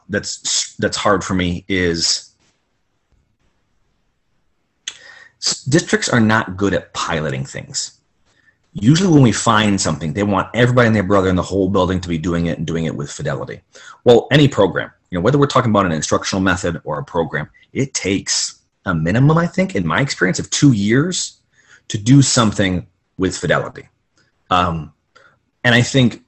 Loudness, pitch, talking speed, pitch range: -16 LUFS, 100 Hz, 165 wpm, 85-125 Hz